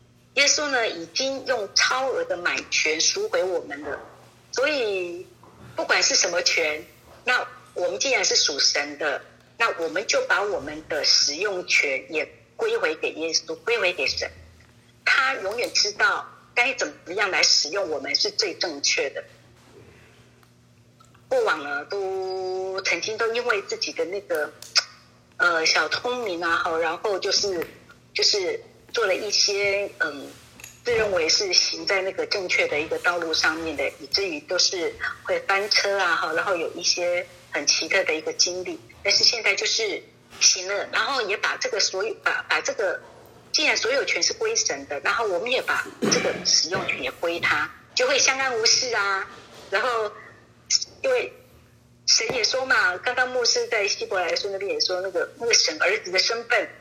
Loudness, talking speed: -22 LUFS, 235 characters per minute